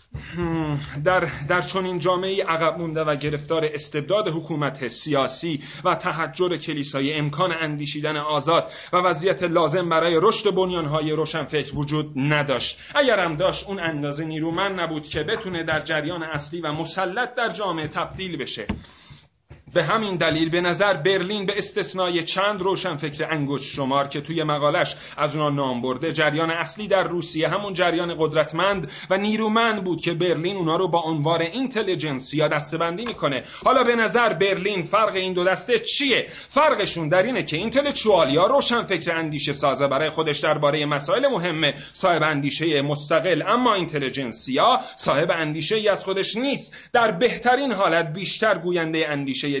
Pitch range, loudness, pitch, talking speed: 150-190 Hz, -22 LUFS, 165 Hz, 150 wpm